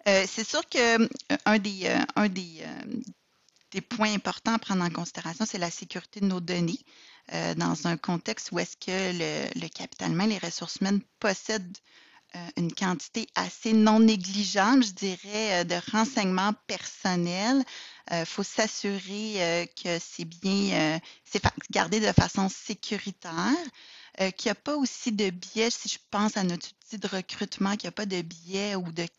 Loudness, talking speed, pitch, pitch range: -28 LUFS, 180 wpm, 200 Hz, 180-220 Hz